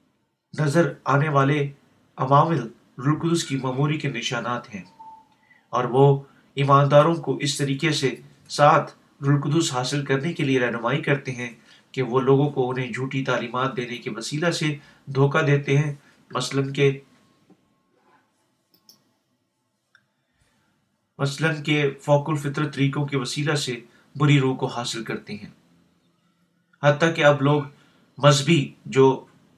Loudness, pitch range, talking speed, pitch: -22 LUFS, 130-150 Hz, 125 wpm, 140 Hz